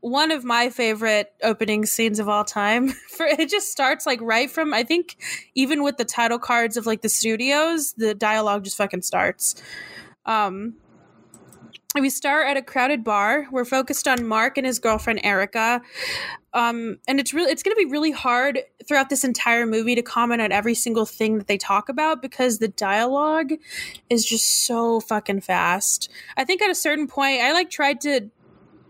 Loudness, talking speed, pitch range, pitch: -21 LUFS, 185 wpm, 220-280 Hz, 240 Hz